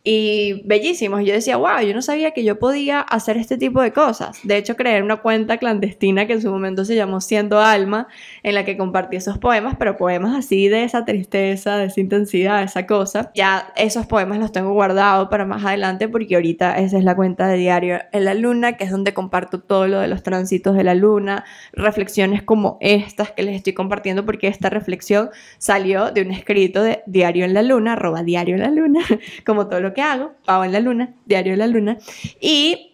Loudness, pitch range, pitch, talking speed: -18 LUFS, 190-220 Hz, 205 Hz, 215 wpm